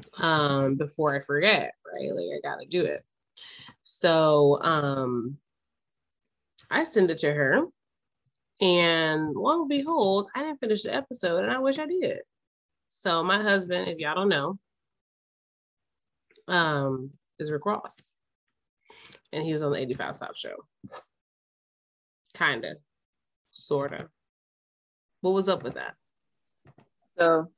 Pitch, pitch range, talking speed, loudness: 165 Hz, 145-200 Hz, 130 wpm, -26 LUFS